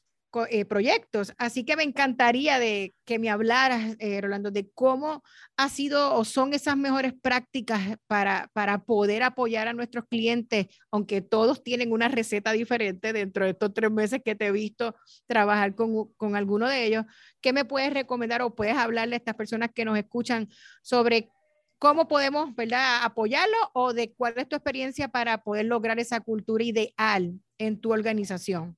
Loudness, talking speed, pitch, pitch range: -26 LUFS, 170 wpm, 230 Hz, 215-255 Hz